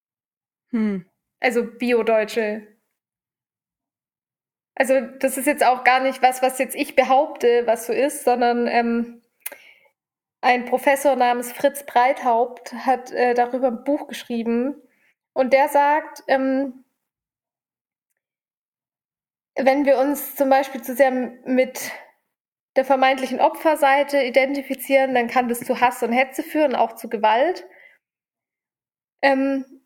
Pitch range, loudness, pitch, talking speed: 245-275 Hz, -20 LUFS, 260 Hz, 115 wpm